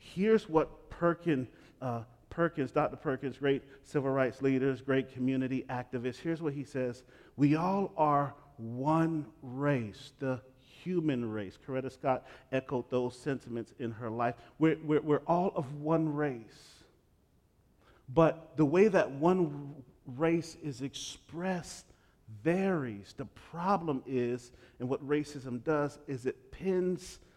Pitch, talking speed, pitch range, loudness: 140 Hz, 130 wpm, 125-160 Hz, -33 LUFS